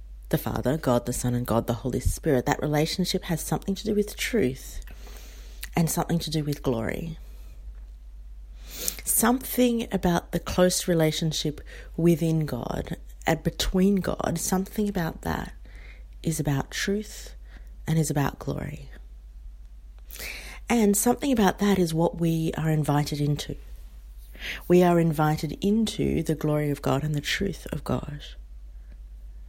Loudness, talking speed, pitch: -26 LUFS, 135 wpm, 150 Hz